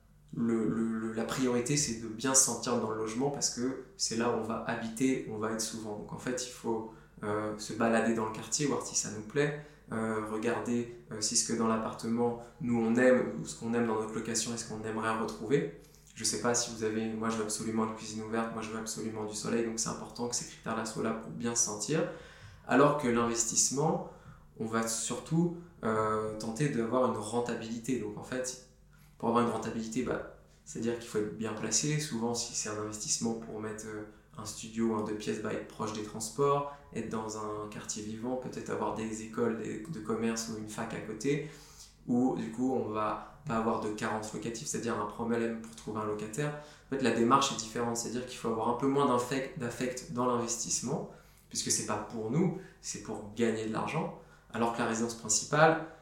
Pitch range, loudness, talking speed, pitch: 110-120 Hz, -33 LUFS, 215 wpm, 115 Hz